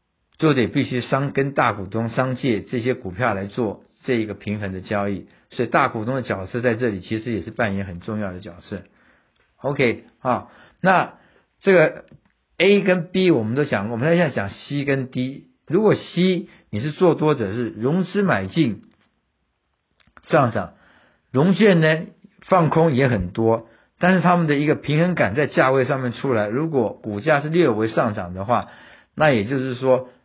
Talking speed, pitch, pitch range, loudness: 250 characters per minute, 130 Hz, 110-155 Hz, -21 LUFS